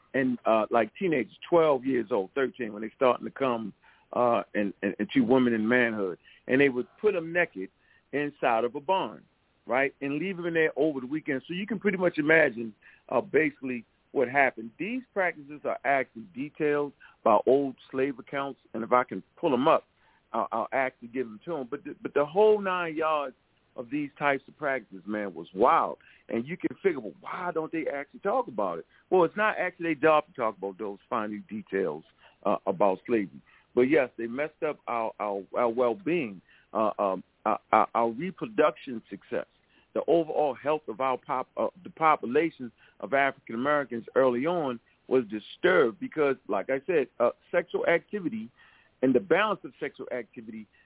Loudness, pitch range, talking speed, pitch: -28 LUFS, 115-160 Hz, 190 wpm, 135 Hz